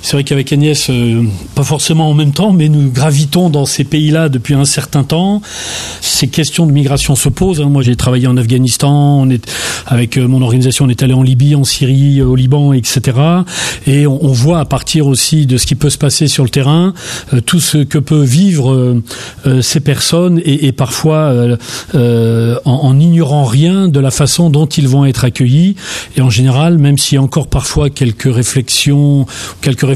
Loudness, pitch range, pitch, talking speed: -10 LUFS, 130-150 Hz, 140 Hz, 205 wpm